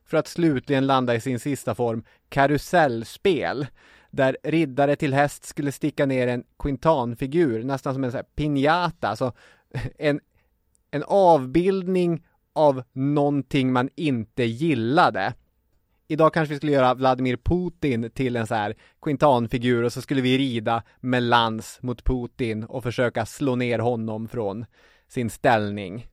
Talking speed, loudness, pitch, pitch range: 140 wpm, -23 LUFS, 130 Hz, 120-145 Hz